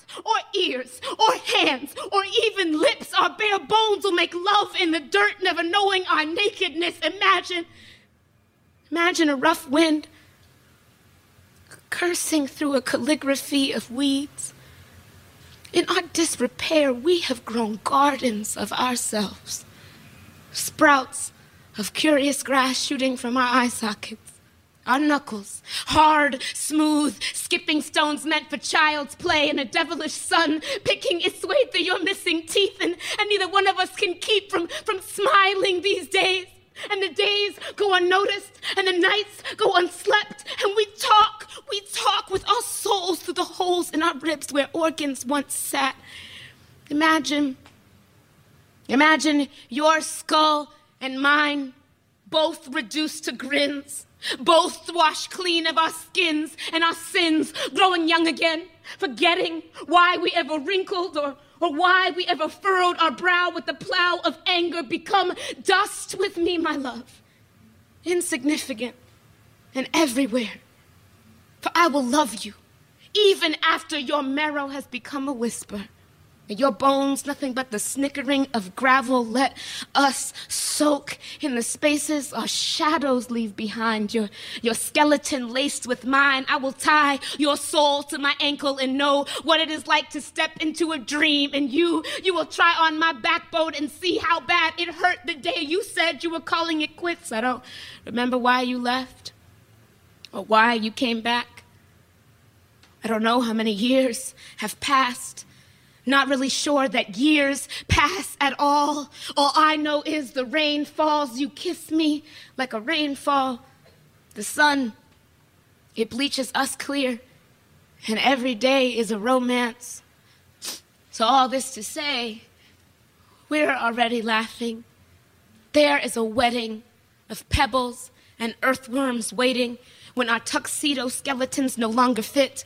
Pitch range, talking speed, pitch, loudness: 260-340 Hz, 140 wpm, 295 Hz, -22 LUFS